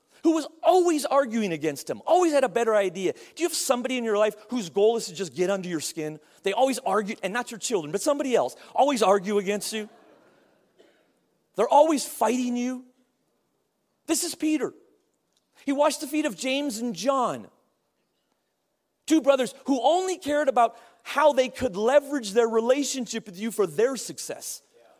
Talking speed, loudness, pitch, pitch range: 175 wpm, -25 LUFS, 250 Hz, 215-290 Hz